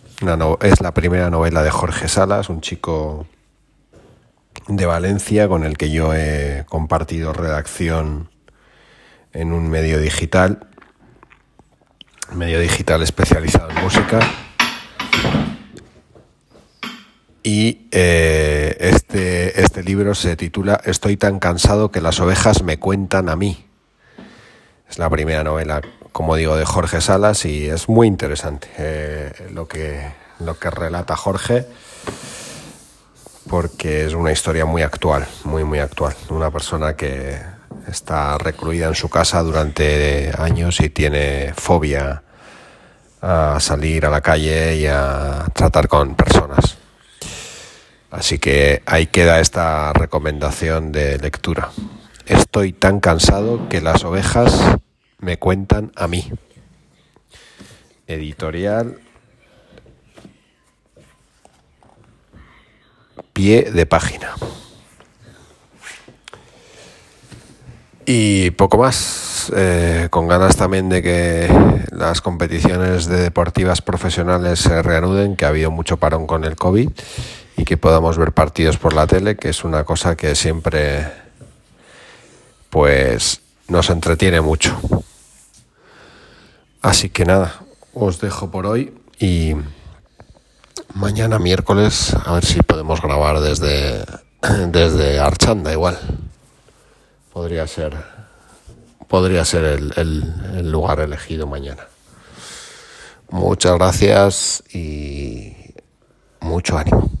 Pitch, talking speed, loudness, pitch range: 85 Hz, 110 wpm, -17 LUFS, 75-95 Hz